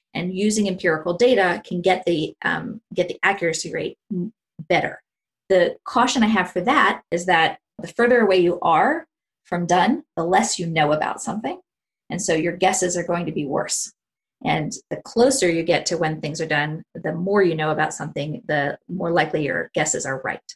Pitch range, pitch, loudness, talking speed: 170-220 Hz, 180 Hz, -21 LUFS, 195 wpm